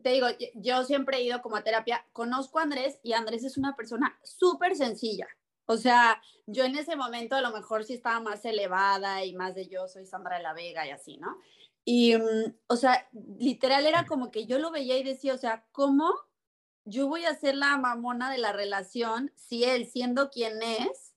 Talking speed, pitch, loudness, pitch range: 210 wpm, 245 Hz, -29 LUFS, 220-270 Hz